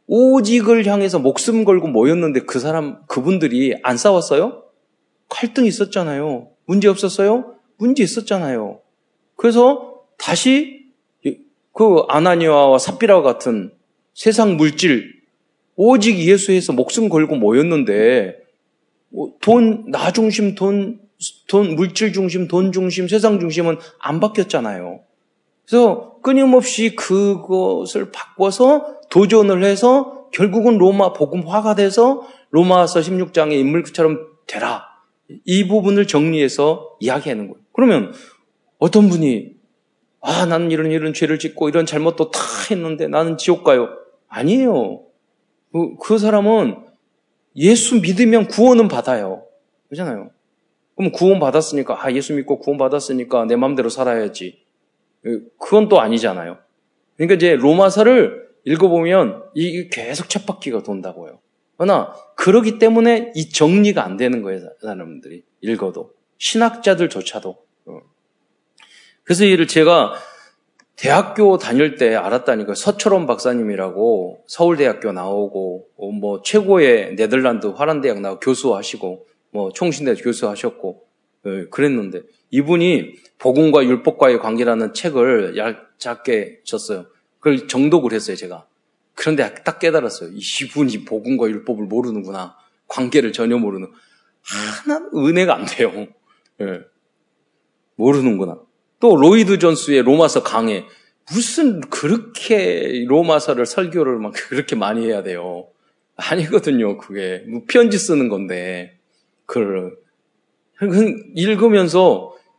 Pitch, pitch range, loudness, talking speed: 180 Hz, 145-220 Hz, -16 LUFS, 275 characters per minute